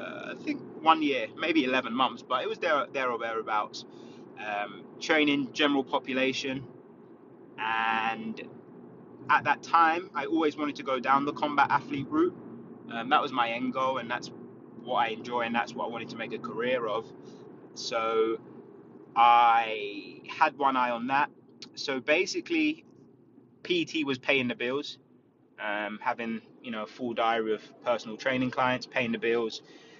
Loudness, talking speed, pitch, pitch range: -28 LUFS, 155 wpm, 130 Hz, 115-160 Hz